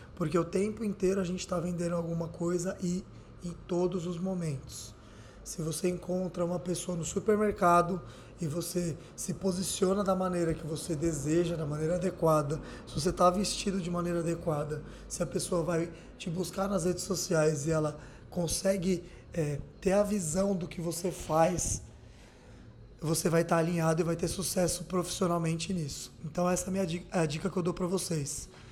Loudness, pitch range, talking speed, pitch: -31 LUFS, 160-185 Hz, 175 wpm, 175 Hz